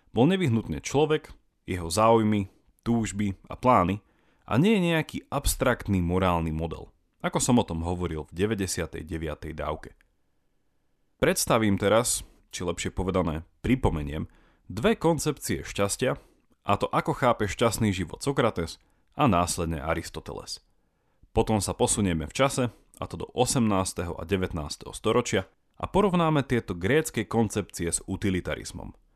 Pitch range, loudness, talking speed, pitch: 85-120 Hz, -27 LUFS, 125 wpm, 100 Hz